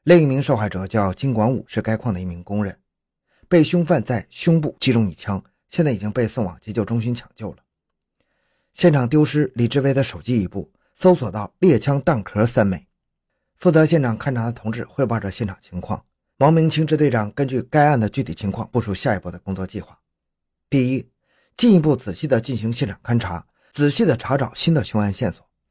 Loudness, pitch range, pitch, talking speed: -20 LUFS, 105-145 Hz, 120 Hz, 300 characters per minute